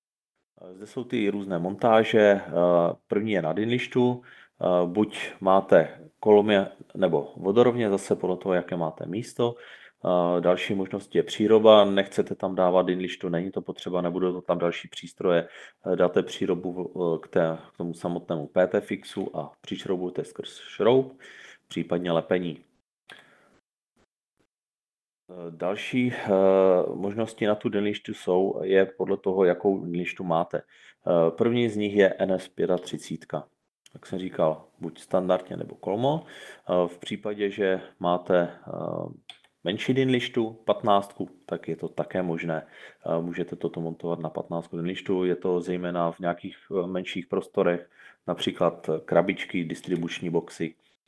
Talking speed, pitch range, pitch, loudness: 120 wpm, 85-105 Hz, 90 Hz, -26 LUFS